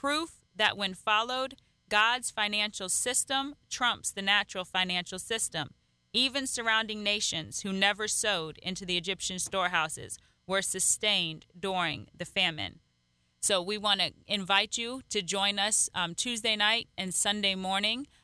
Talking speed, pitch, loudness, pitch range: 140 wpm, 200 Hz, -29 LUFS, 180-215 Hz